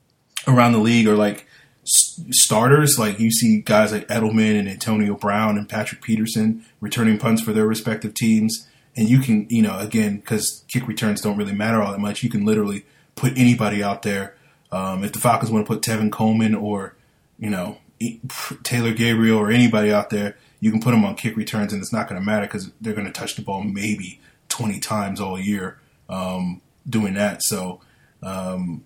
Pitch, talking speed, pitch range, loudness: 110 Hz, 195 wpm, 105-115 Hz, -20 LUFS